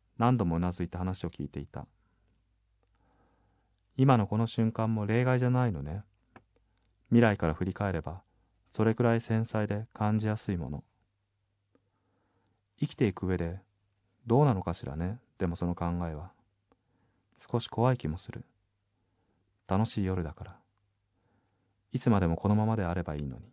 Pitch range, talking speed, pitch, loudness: 95-110 Hz, 285 characters per minute, 100 Hz, -30 LUFS